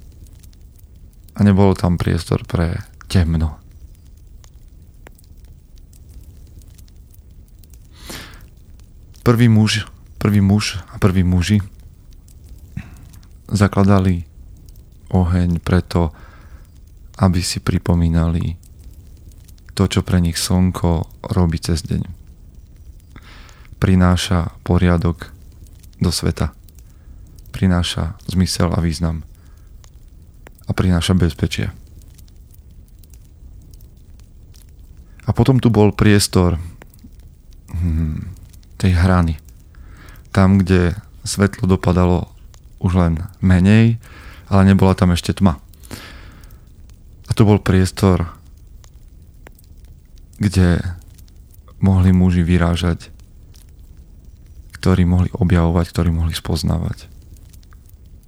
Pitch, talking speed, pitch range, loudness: 90 Hz, 75 wpm, 85-95 Hz, -17 LUFS